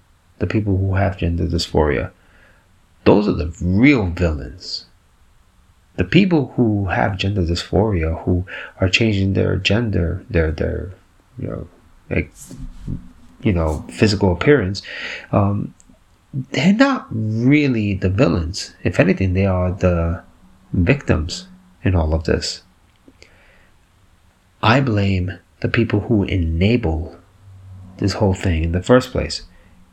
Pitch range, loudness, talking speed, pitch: 85-105 Hz, -19 LUFS, 120 wpm, 95 Hz